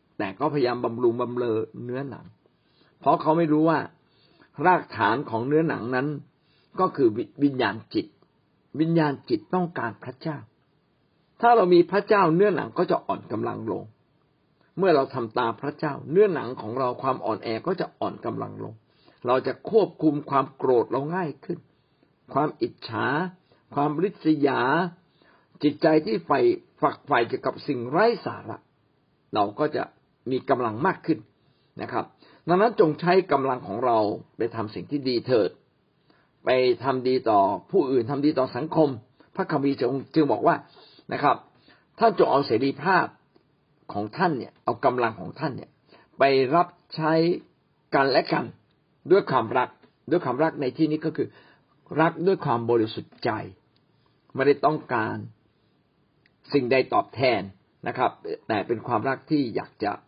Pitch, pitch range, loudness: 145 Hz, 130-165 Hz, -25 LUFS